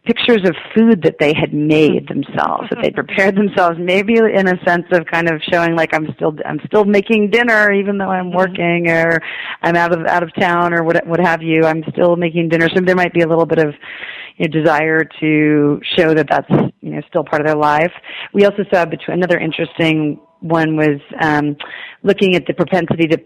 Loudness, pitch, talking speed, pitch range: -14 LUFS, 170 Hz, 215 wpm, 160-185 Hz